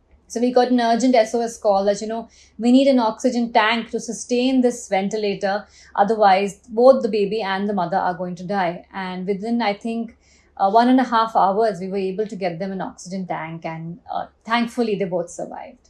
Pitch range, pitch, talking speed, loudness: 195-235 Hz, 215 Hz, 210 wpm, -20 LUFS